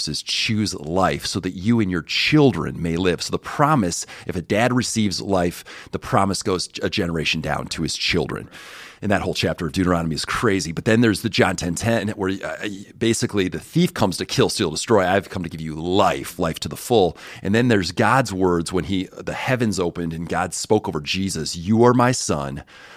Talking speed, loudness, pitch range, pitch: 215 wpm, -21 LUFS, 85-110 Hz, 95 Hz